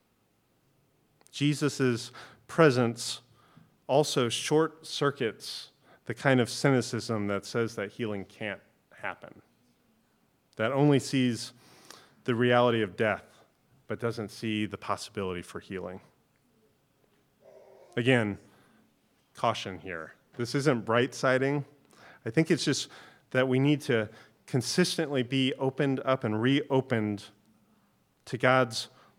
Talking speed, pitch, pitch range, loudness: 105 wpm, 125 Hz, 110-135 Hz, -29 LUFS